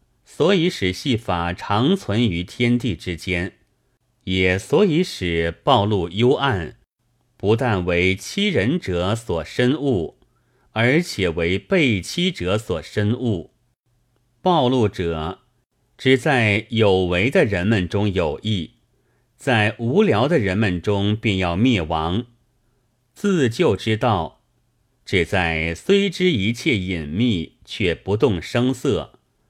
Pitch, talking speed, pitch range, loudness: 115 Hz, 160 characters per minute, 95-125 Hz, -20 LUFS